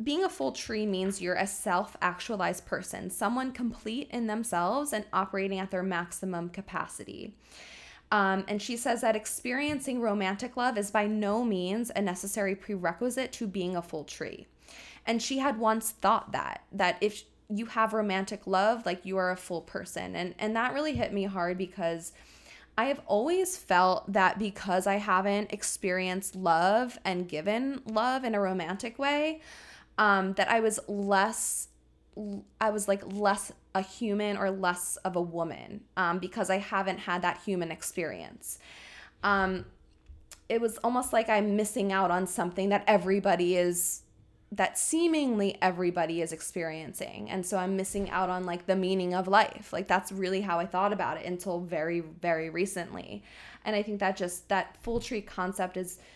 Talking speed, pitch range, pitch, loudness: 170 wpm, 180-220 Hz, 195 Hz, -30 LUFS